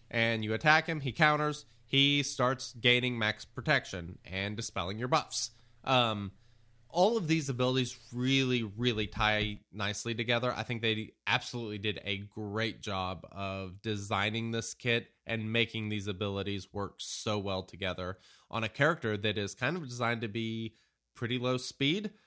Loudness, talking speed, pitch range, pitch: -32 LUFS, 155 wpm, 105-125 Hz, 115 Hz